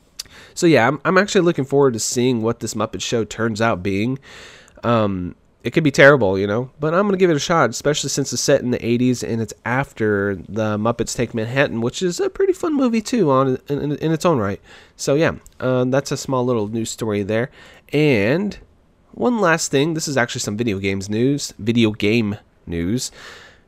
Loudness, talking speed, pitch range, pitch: -19 LUFS, 205 wpm, 110-145 Hz, 125 Hz